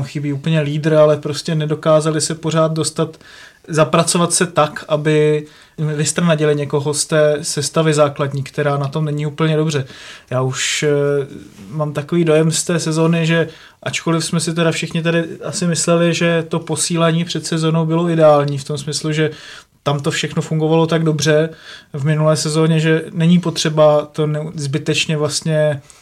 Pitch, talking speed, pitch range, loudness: 155 Hz, 155 wpm, 150-165 Hz, -16 LUFS